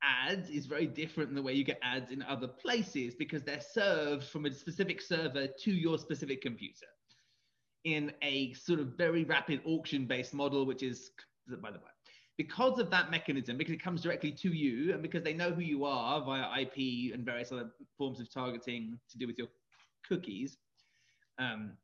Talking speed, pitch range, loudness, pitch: 185 wpm, 130-165 Hz, -36 LUFS, 145 Hz